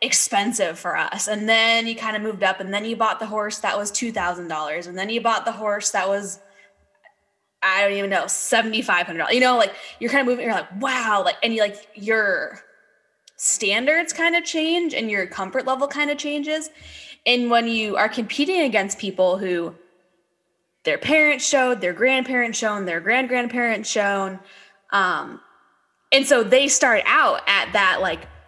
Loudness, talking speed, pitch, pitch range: -20 LUFS, 190 wpm, 220 Hz, 200-260 Hz